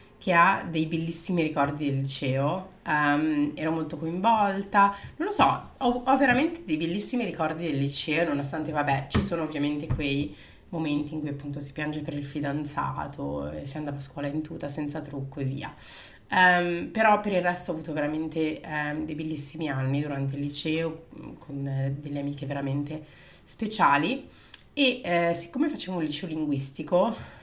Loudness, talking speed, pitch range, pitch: -27 LUFS, 165 wpm, 145-170 Hz, 155 Hz